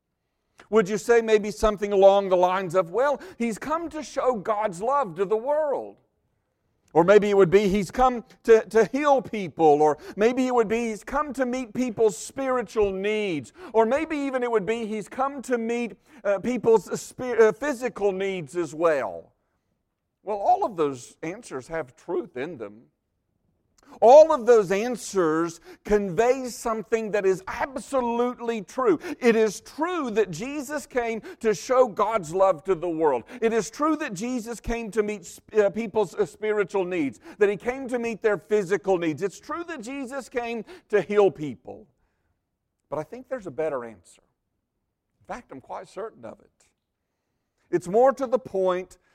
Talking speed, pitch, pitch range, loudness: 170 wpm, 220 Hz, 195-250 Hz, -24 LUFS